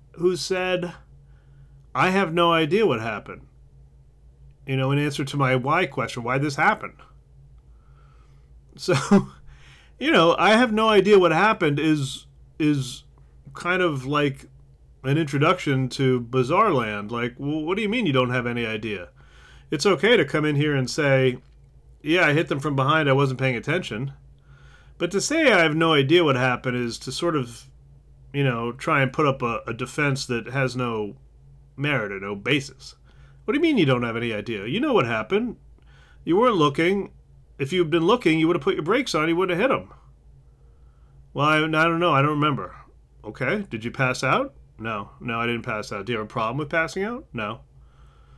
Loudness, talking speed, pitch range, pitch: -22 LUFS, 195 wpm, 120-160 Hz, 135 Hz